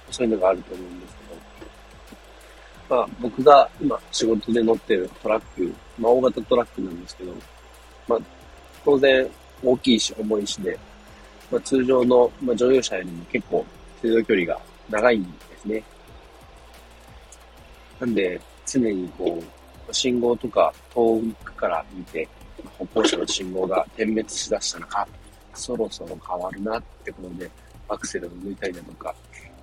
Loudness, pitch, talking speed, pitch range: -23 LUFS, 95 Hz, 285 characters per minute, 75-115 Hz